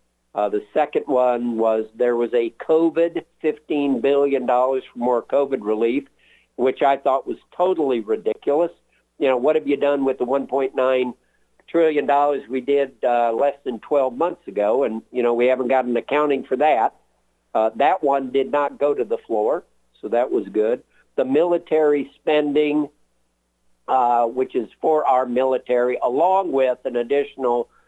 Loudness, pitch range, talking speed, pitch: -21 LUFS, 120-145 Hz, 160 wpm, 130 Hz